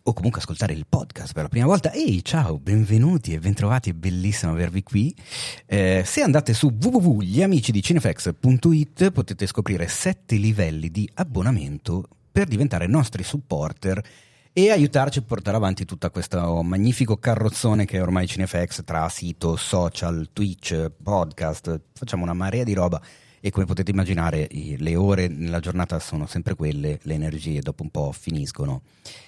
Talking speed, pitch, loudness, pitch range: 150 wpm, 100 Hz, -23 LUFS, 85-125 Hz